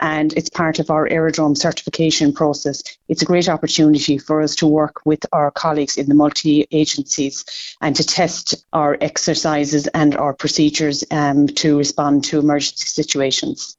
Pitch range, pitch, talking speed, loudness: 145-160 Hz, 150 Hz, 160 wpm, -17 LUFS